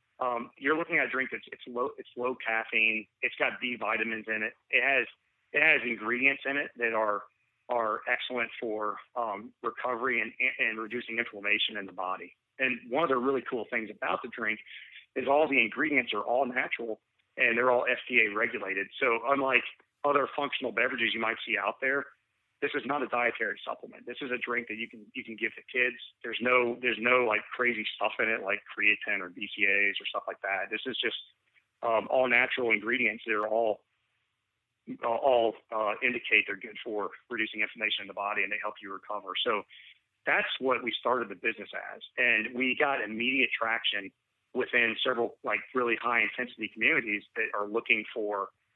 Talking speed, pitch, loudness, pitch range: 190 wpm, 120 Hz, -29 LUFS, 110-130 Hz